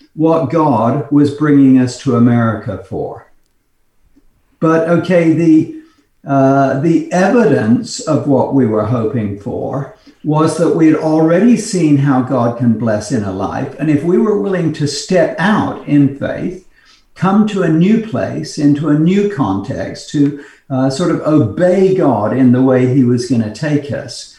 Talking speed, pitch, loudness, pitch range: 165 wpm, 145 Hz, -13 LUFS, 130-165 Hz